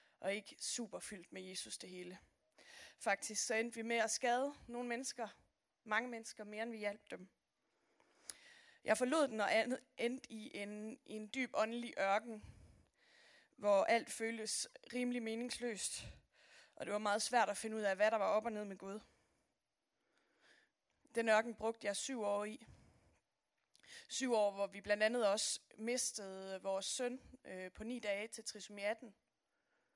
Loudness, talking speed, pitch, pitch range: -40 LUFS, 165 wpm, 220 Hz, 205-240 Hz